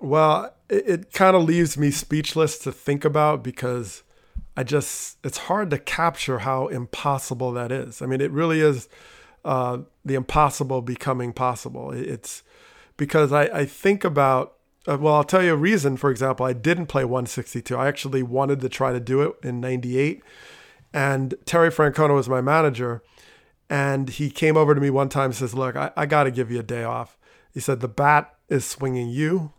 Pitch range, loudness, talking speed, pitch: 130-155 Hz, -22 LUFS, 190 wpm, 140 Hz